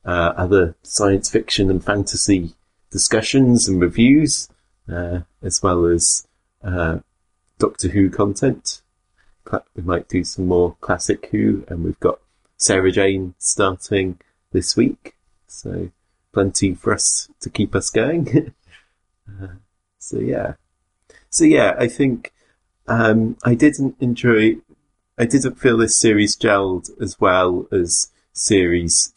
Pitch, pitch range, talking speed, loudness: 95 Hz, 90-110 Hz, 125 wpm, -18 LUFS